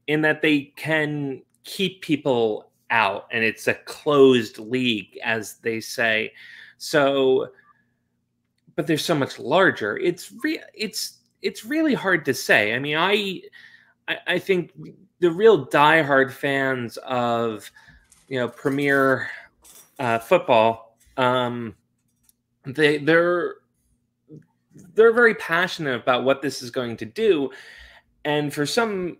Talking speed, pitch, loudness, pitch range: 125 wpm, 145 Hz, -21 LUFS, 125-180 Hz